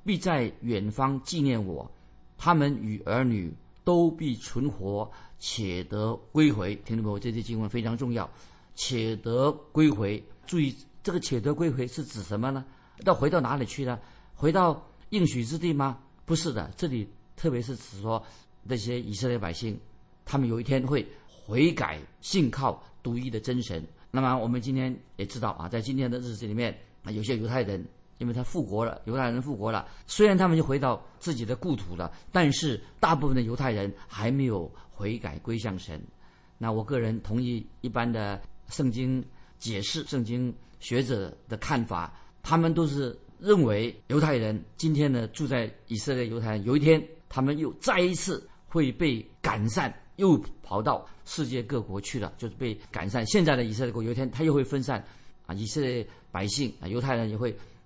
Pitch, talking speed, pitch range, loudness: 120 Hz, 265 characters per minute, 110-140 Hz, -29 LUFS